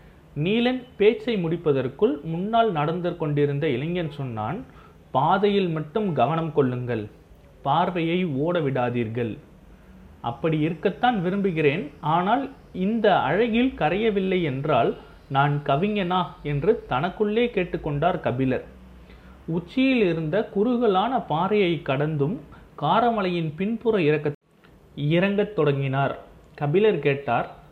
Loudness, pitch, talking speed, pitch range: -24 LUFS, 170 Hz, 90 wpm, 145-205 Hz